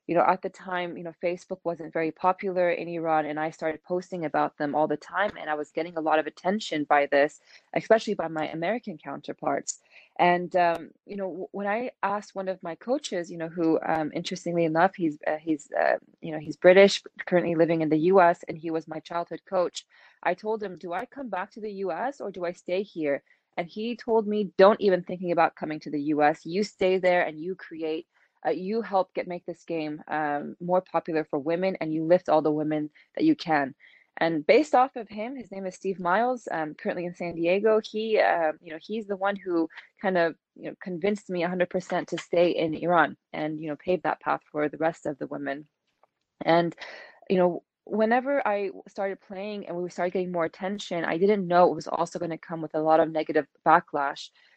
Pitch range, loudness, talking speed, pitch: 160-195 Hz, -27 LUFS, 220 wpm, 175 Hz